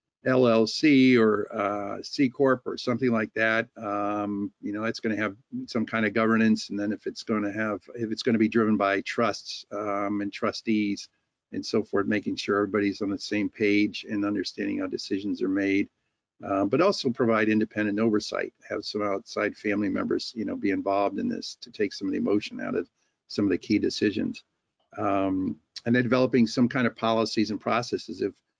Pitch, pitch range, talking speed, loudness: 110 Hz, 100-115 Hz, 200 wpm, -26 LUFS